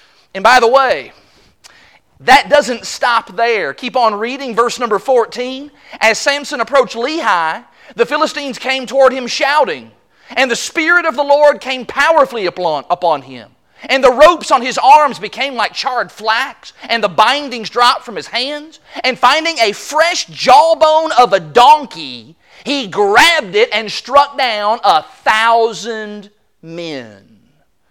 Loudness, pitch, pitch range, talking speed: -12 LUFS, 255 Hz, 230-295 Hz, 145 wpm